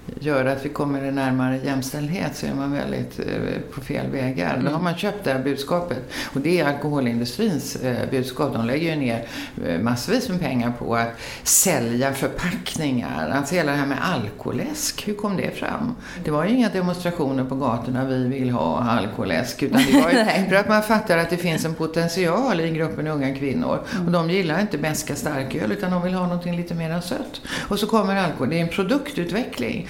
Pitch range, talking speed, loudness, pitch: 135-195 Hz, 205 wpm, -23 LUFS, 160 Hz